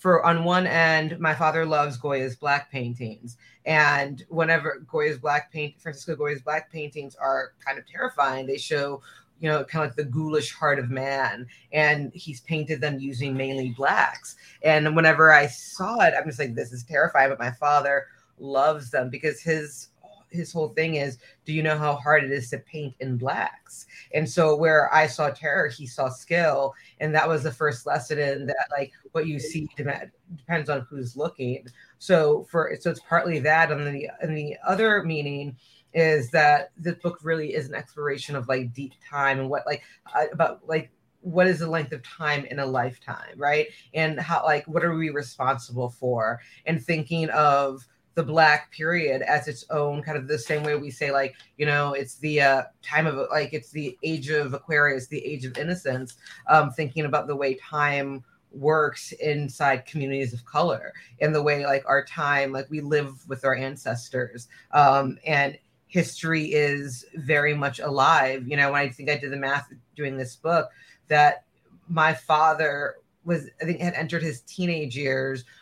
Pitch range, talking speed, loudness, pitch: 135-155 Hz, 185 wpm, -24 LUFS, 145 Hz